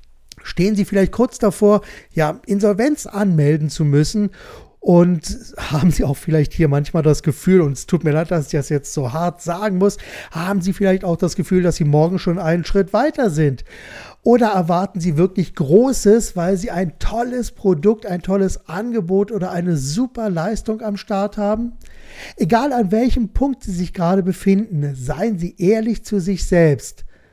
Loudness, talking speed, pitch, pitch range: -18 LUFS, 175 wpm, 185 Hz, 160-210 Hz